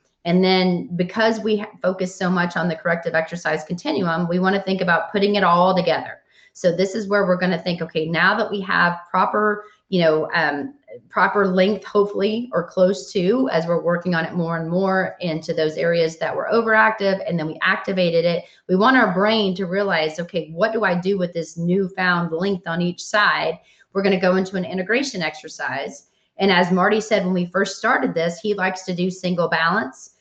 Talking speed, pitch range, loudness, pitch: 205 wpm, 170-200 Hz, -20 LUFS, 185 Hz